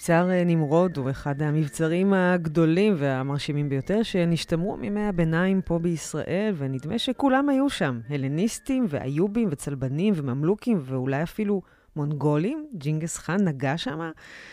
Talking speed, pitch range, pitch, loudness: 115 wpm, 145-200 Hz, 170 Hz, -25 LUFS